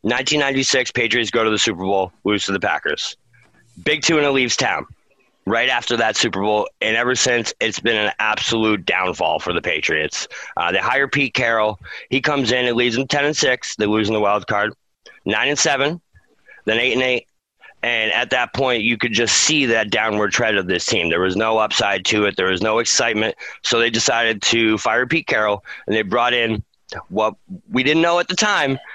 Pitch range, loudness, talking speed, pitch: 105-135 Hz, -18 LUFS, 210 wpm, 115 Hz